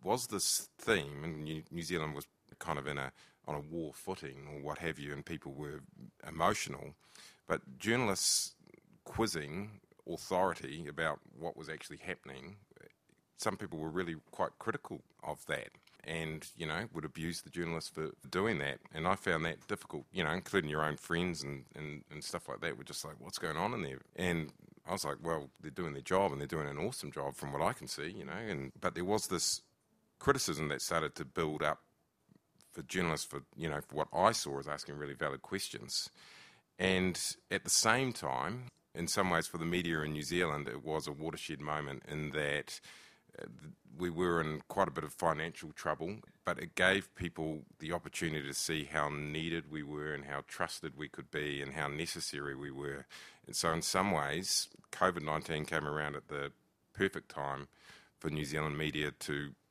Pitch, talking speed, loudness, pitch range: 75 Hz, 195 wpm, -37 LUFS, 70-85 Hz